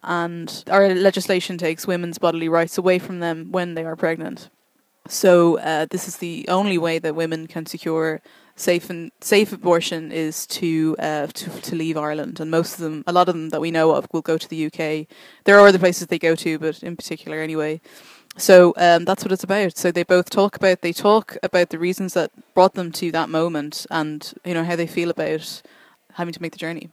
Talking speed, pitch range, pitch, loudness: 220 wpm, 160-185 Hz, 170 Hz, -20 LUFS